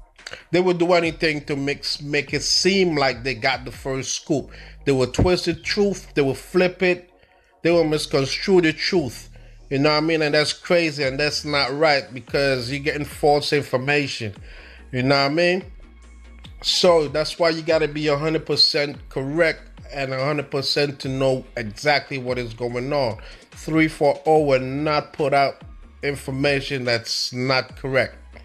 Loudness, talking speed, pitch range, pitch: -21 LUFS, 160 wpm, 130-160 Hz, 145 Hz